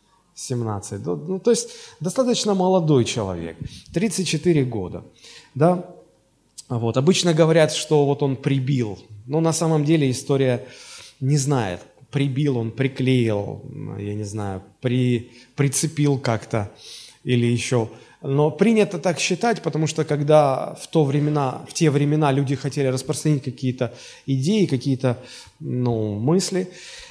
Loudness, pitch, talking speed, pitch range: -21 LUFS, 140 Hz, 125 wpm, 120-160 Hz